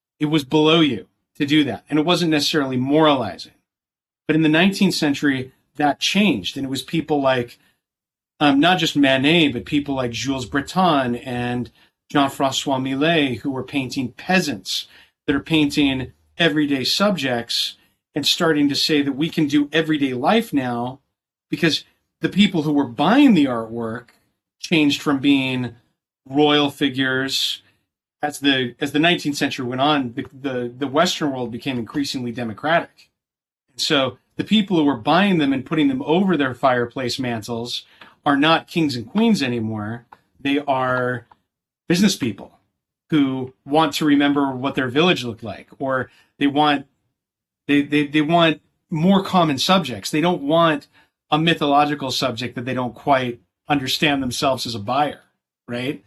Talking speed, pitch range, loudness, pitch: 155 wpm, 130-155 Hz, -19 LUFS, 145 Hz